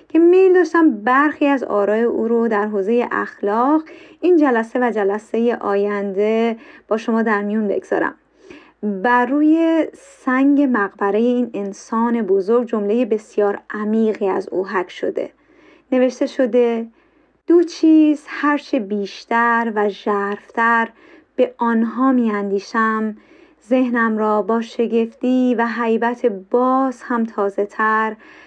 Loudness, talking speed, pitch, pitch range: -18 LUFS, 120 wpm, 235 Hz, 210-275 Hz